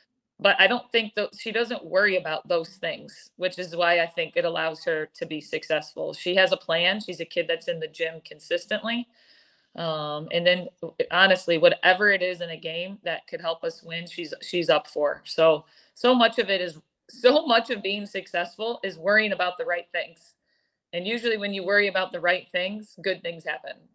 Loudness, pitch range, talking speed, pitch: -25 LUFS, 170-225 Hz, 205 wpm, 185 Hz